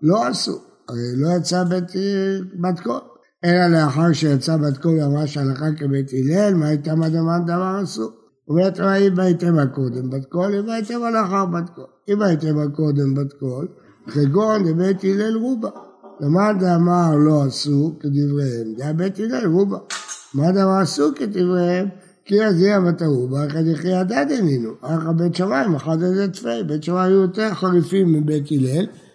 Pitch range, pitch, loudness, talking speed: 150-190 Hz, 170 Hz, -19 LUFS, 150 wpm